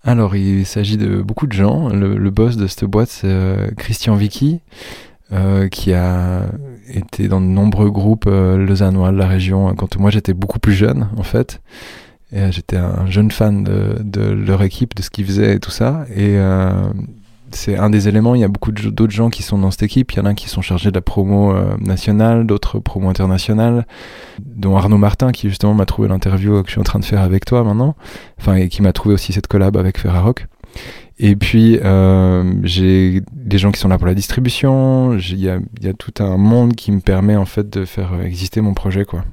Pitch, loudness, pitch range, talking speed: 100 Hz, -15 LUFS, 95-110 Hz, 220 wpm